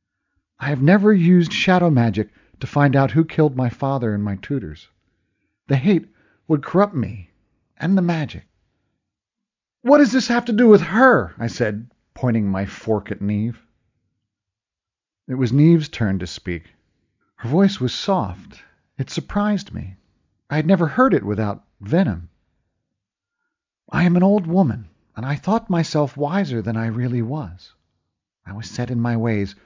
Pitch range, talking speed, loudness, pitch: 105-170 Hz, 160 wpm, -19 LUFS, 125 Hz